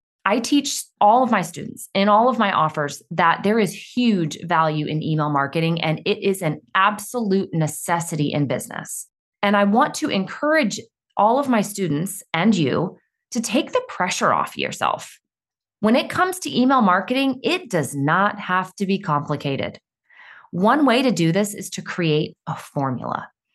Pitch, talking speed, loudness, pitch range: 195 Hz, 170 wpm, -21 LUFS, 155-225 Hz